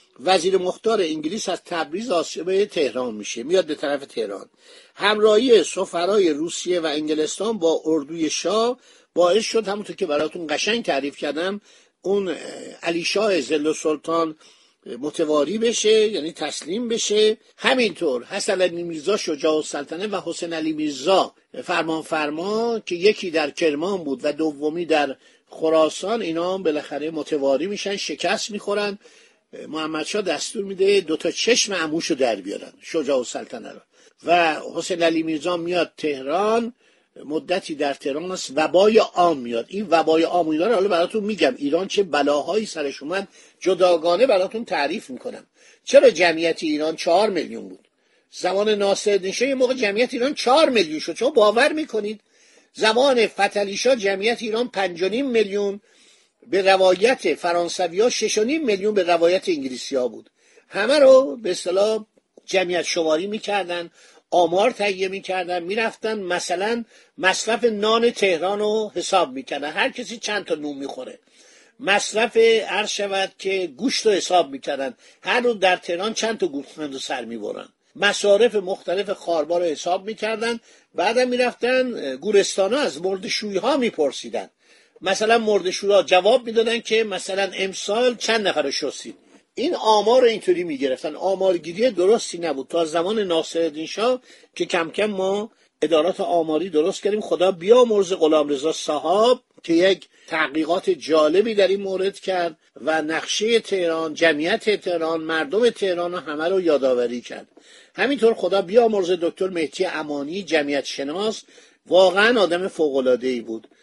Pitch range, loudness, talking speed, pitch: 160-220 Hz, -21 LUFS, 140 wpm, 190 Hz